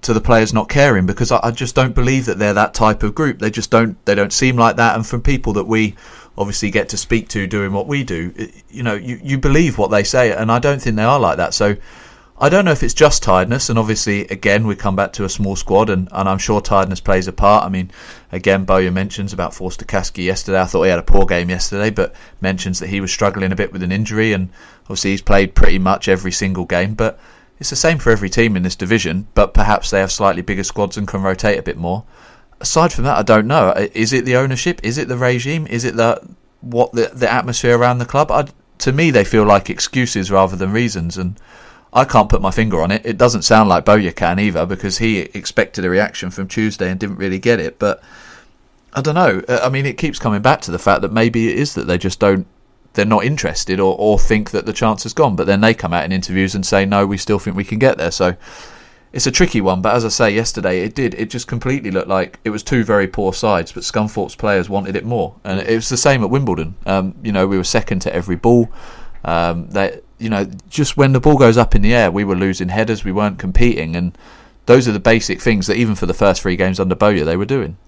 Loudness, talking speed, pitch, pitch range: -16 LUFS, 255 wpm, 105 Hz, 95-120 Hz